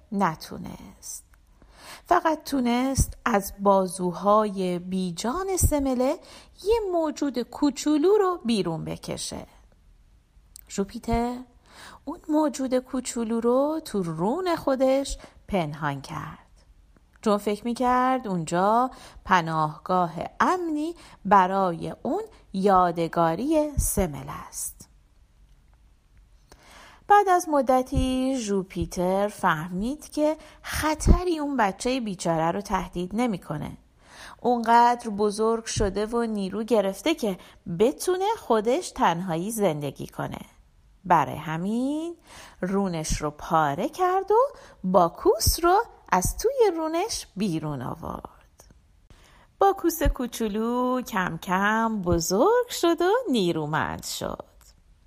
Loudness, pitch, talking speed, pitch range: -25 LUFS, 230 Hz, 90 wpm, 185-300 Hz